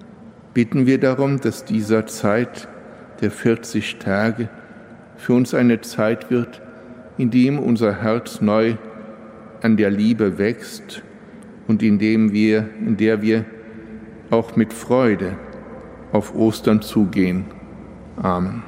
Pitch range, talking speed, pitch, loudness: 110-120 Hz, 120 wpm, 110 Hz, -19 LUFS